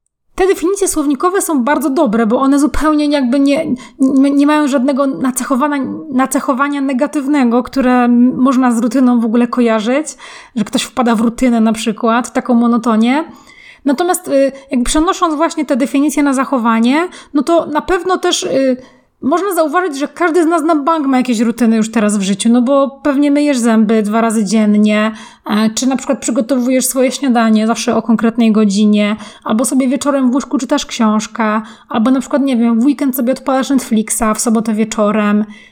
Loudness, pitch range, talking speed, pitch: -13 LUFS, 230-290 Hz, 175 wpm, 265 Hz